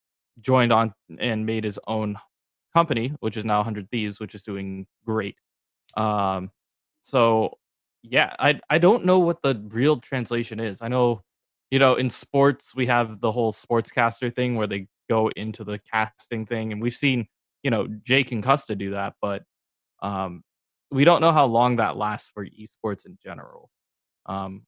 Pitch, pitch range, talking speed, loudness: 110 Hz, 105-125 Hz, 175 wpm, -23 LUFS